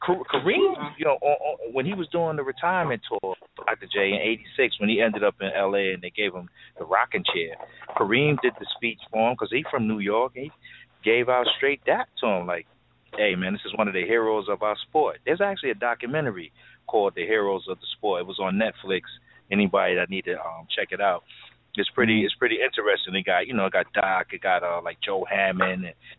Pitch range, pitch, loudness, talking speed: 100-150 Hz, 120 Hz, -25 LUFS, 230 wpm